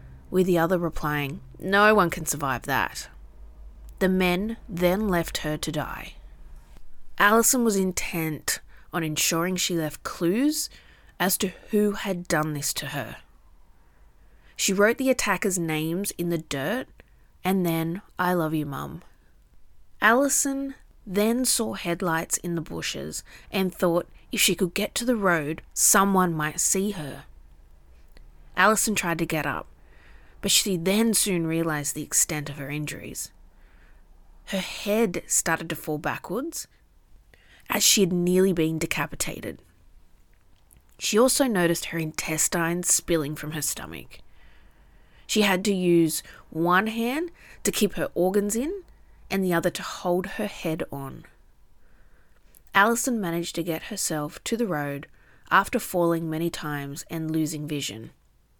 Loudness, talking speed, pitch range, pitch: -25 LUFS, 140 wpm, 140-195 Hz, 165 Hz